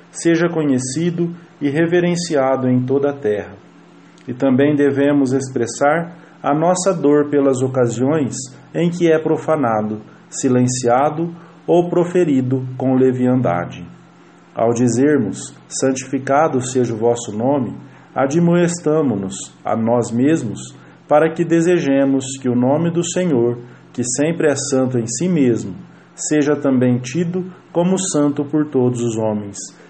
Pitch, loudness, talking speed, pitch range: 140 Hz, -17 LUFS, 120 wpm, 125-165 Hz